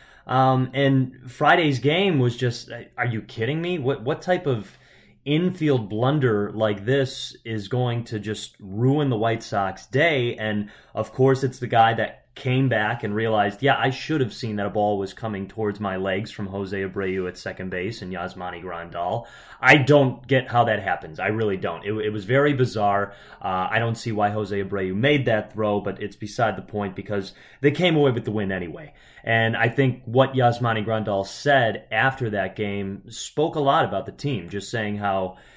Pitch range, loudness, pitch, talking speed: 100-130 Hz, -23 LUFS, 115 Hz, 195 wpm